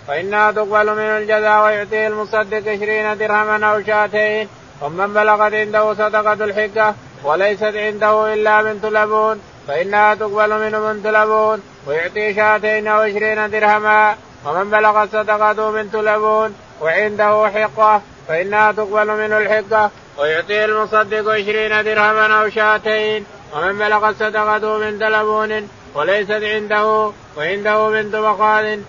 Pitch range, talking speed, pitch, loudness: 210-215 Hz, 120 wpm, 215 Hz, -15 LUFS